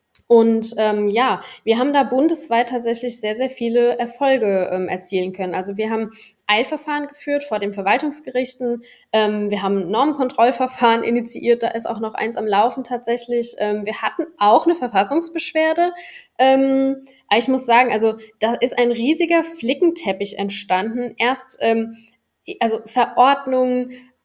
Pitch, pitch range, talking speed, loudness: 240 Hz, 220-260 Hz, 140 wpm, -19 LUFS